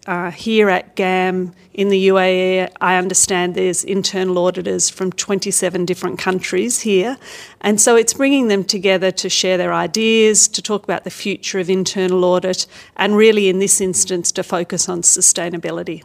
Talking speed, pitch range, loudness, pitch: 165 wpm, 180-200 Hz, -15 LUFS, 185 Hz